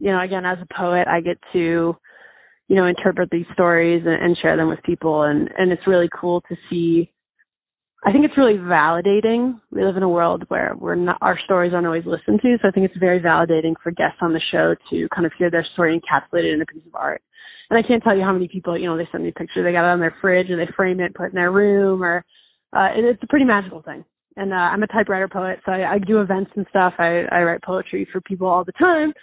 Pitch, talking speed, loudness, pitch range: 180 Hz, 265 wpm, -19 LUFS, 170-195 Hz